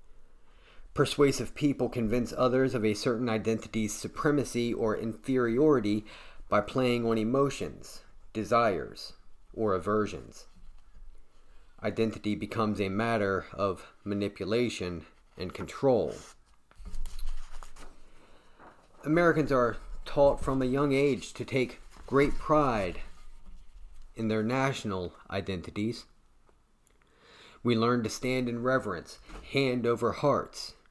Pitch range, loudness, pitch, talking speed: 105-130 Hz, -29 LUFS, 115 Hz, 95 wpm